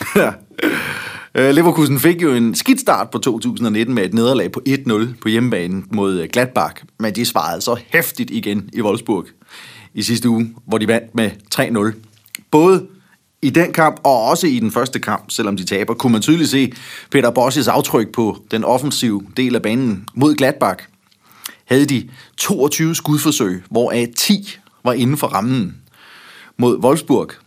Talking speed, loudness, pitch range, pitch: 160 wpm, -16 LUFS, 110-155 Hz, 125 Hz